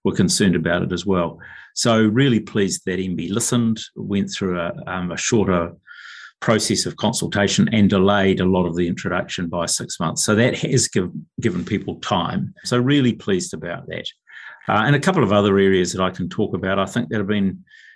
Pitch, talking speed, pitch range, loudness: 100 Hz, 200 wpm, 90-110 Hz, -20 LUFS